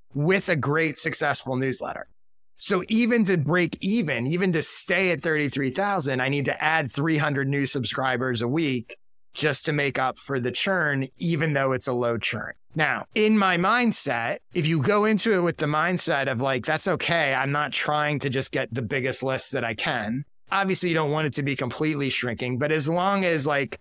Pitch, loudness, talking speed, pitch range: 150 Hz, -24 LUFS, 200 wpm, 130-175 Hz